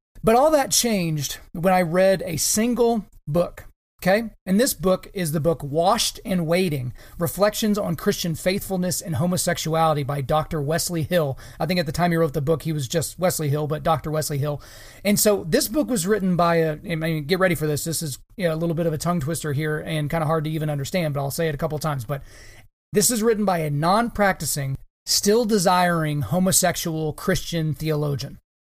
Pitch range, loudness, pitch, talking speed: 155-185 Hz, -22 LUFS, 165 Hz, 215 wpm